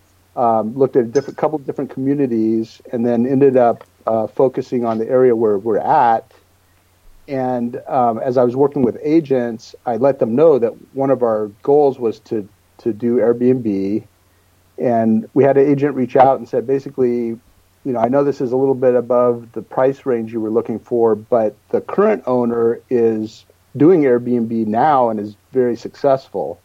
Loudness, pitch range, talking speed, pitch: -17 LUFS, 110-135 Hz, 185 wpm, 120 Hz